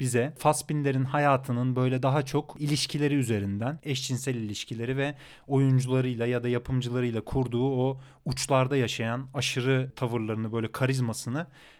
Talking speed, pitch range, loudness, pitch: 115 wpm, 120-140 Hz, -28 LUFS, 130 Hz